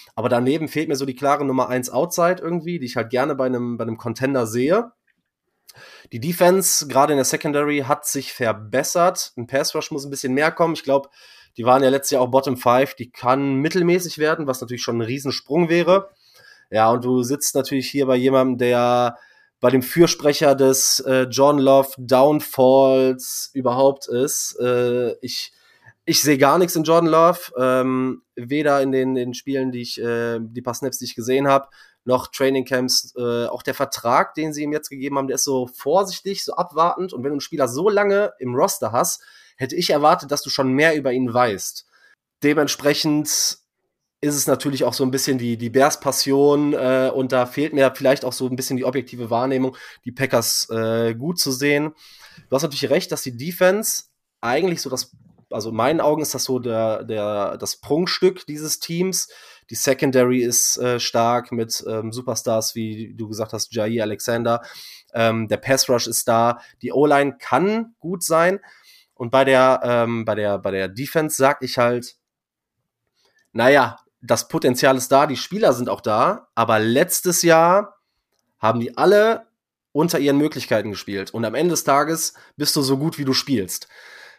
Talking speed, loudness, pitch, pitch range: 185 wpm, -19 LUFS, 135 Hz, 125-150 Hz